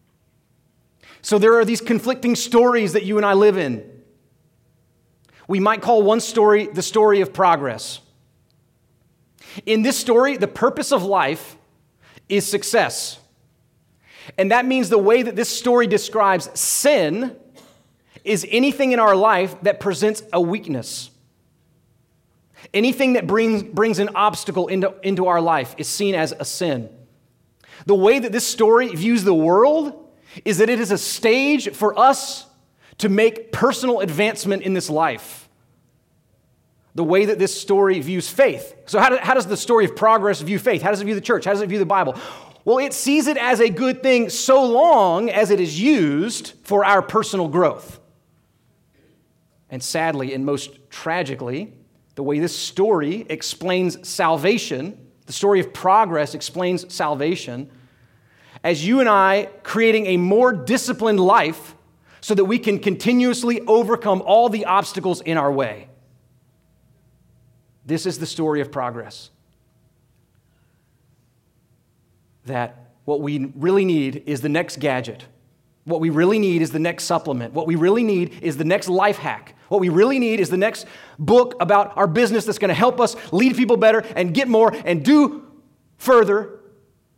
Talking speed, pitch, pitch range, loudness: 160 wpm, 195 Hz, 155-225 Hz, -18 LUFS